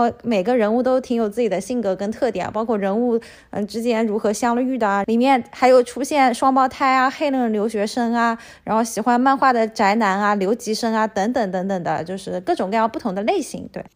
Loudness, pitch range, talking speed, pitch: -19 LUFS, 205-250 Hz, 320 characters per minute, 230 Hz